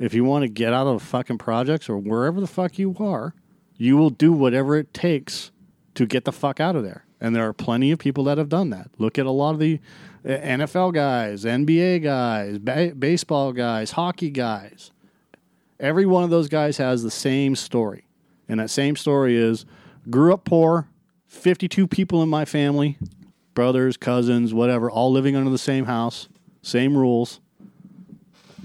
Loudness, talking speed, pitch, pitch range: -21 LUFS, 180 wpm, 140 Hz, 125-175 Hz